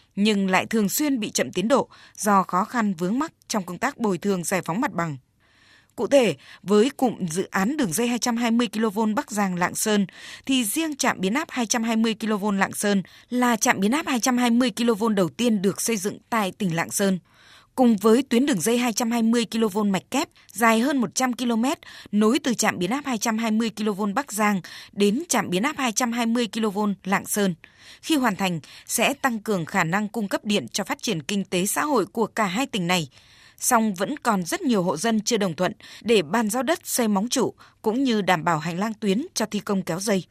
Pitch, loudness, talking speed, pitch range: 220 Hz, -23 LUFS, 210 wpm, 195-245 Hz